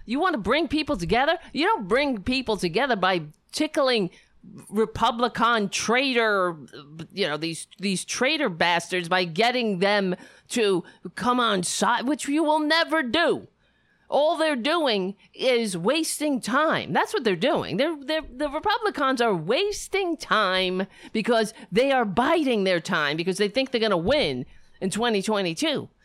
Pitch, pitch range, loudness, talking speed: 235 Hz, 195-295 Hz, -24 LUFS, 150 wpm